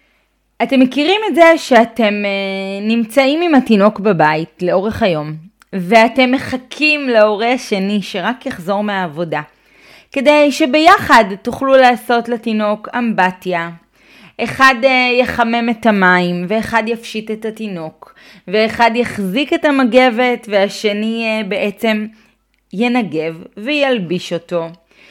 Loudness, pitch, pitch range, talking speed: -14 LUFS, 225 Hz, 195-255 Hz, 100 wpm